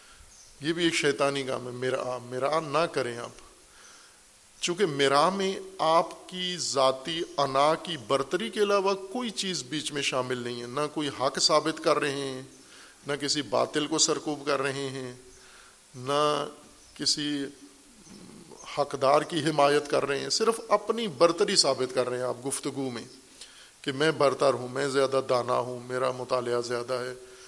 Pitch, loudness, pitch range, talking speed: 140 Hz, -27 LUFS, 130-160 Hz, 160 wpm